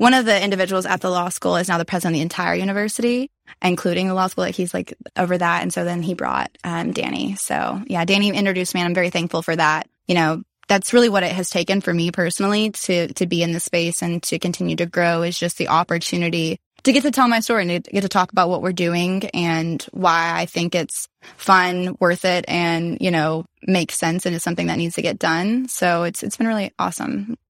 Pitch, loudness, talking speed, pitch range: 180 Hz, -20 LUFS, 245 wpm, 170-195 Hz